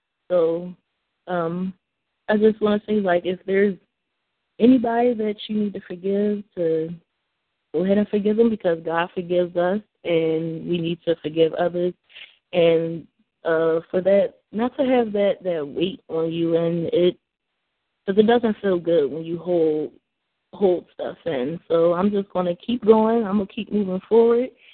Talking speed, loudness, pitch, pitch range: 165 wpm, -22 LUFS, 185 Hz, 170-210 Hz